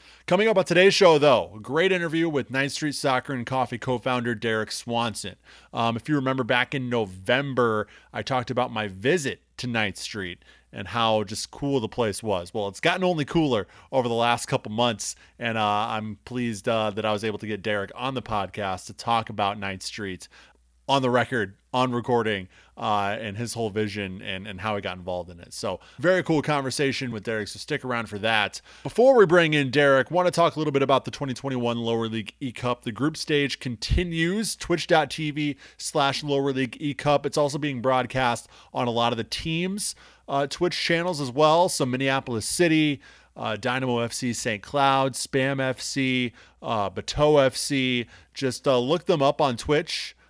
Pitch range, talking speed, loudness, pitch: 110-145 Hz, 195 wpm, -25 LUFS, 125 Hz